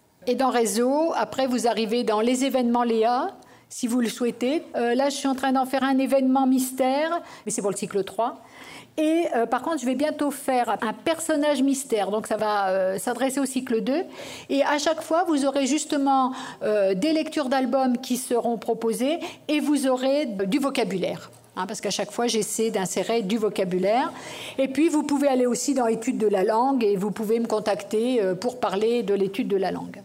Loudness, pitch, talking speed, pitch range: -24 LUFS, 250 Hz, 205 wpm, 220-275 Hz